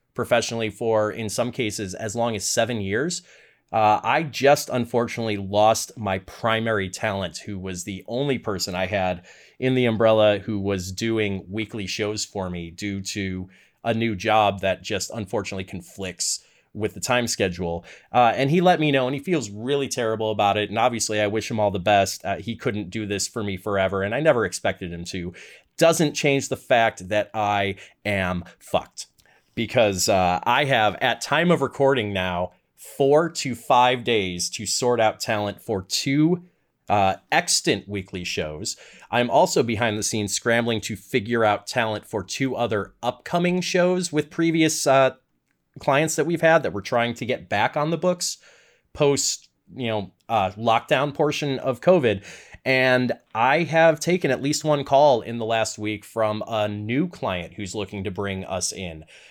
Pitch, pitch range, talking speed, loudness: 110 Hz, 100-130 Hz, 175 wpm, -23 LUFS